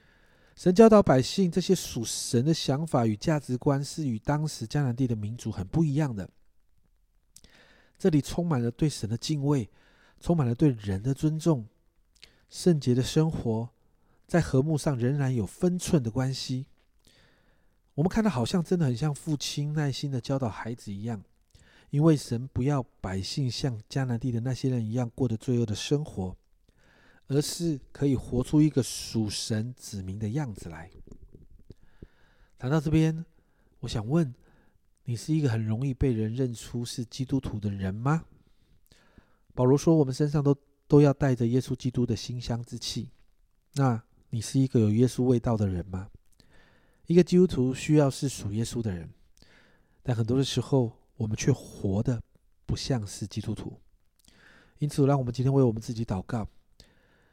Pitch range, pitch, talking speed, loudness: 110-145 Hz, 125 Hz, 240 characters per minute, -28 LUFS